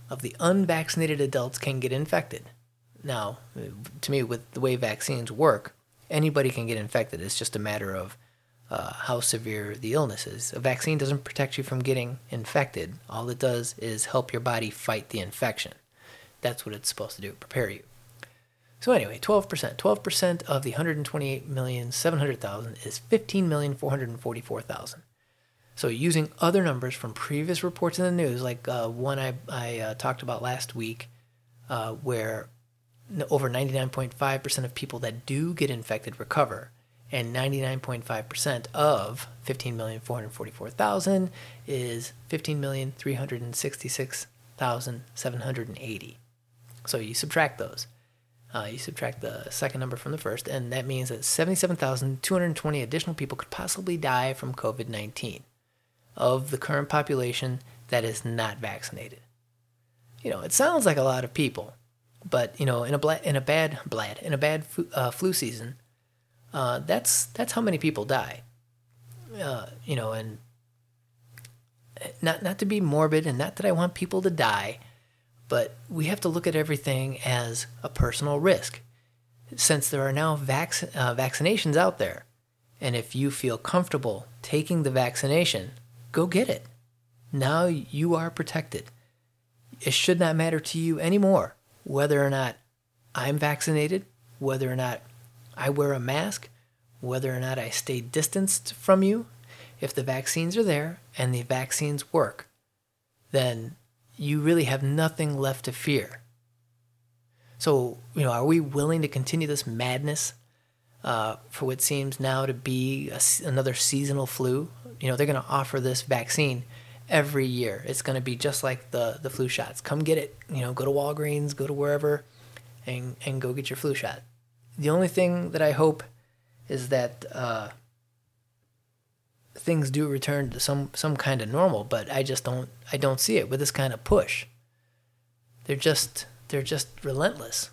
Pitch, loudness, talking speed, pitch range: 130 Hz, -28 LUFS, 155 wpm, 120-145 Hz